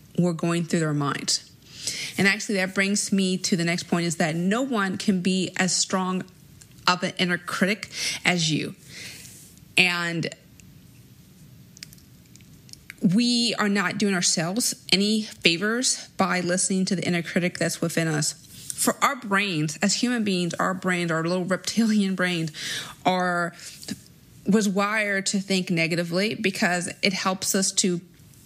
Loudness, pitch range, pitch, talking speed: -24 LUFS, 170-200 Hz, 185 Hz, 145 wpm